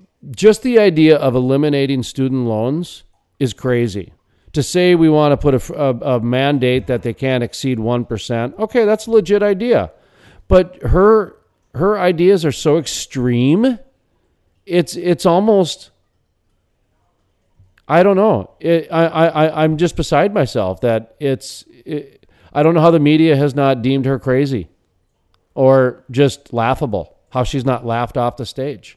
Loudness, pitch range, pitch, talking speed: -15 LUFS, 120-170 Hz, 135 Hz, 150 wpm